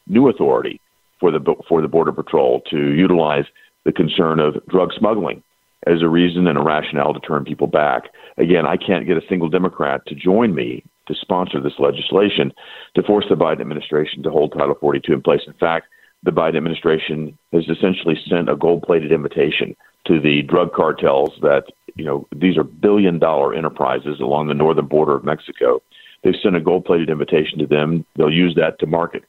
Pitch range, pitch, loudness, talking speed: 75-90 Hz, 80 Hz, -17 LUFS, 190 wpm